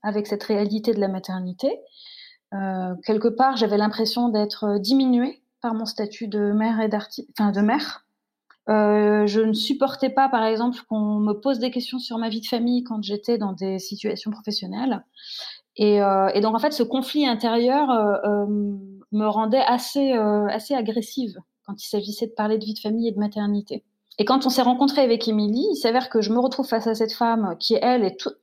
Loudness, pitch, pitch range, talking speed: -22 LUFS, 220 Hz, 210-250 Hz, 205 wpm